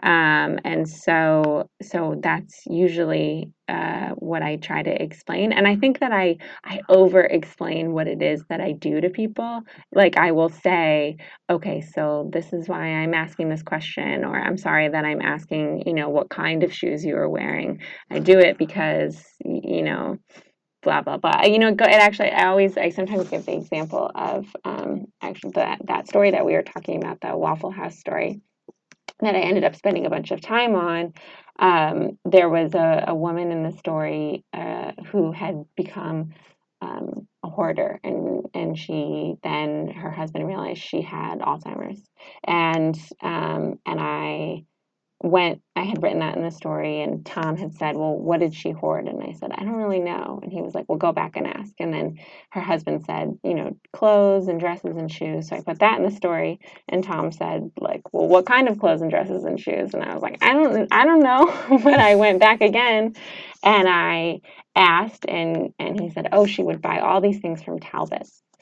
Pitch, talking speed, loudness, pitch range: 175 Hz, 200 wpm, -21 LUFS, 160-205 Hz